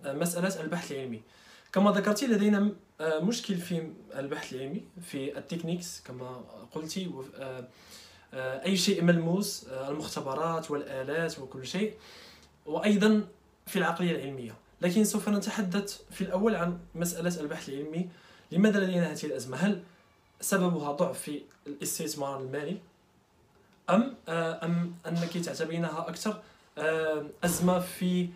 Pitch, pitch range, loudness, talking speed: 170 Hz, 150-195 Hz, -31 LUFS, 105 wpm